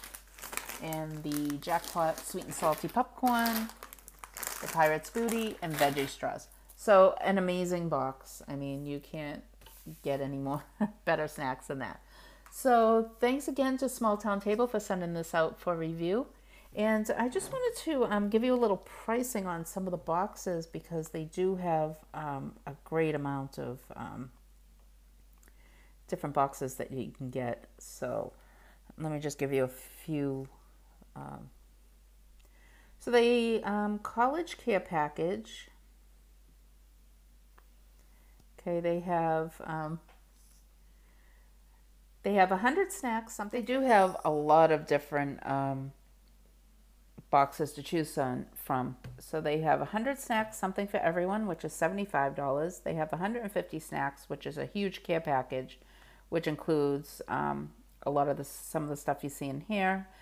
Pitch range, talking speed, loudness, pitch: 140-200 Hz, 145 wpm, -32 LUFS, 160 Hz